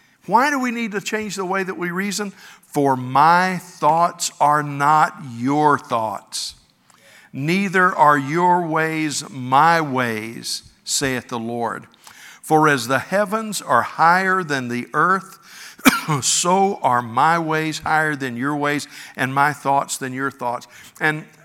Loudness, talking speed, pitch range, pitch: -19 LUFS, 145 wpm, 135-180 Hz, 155 Hz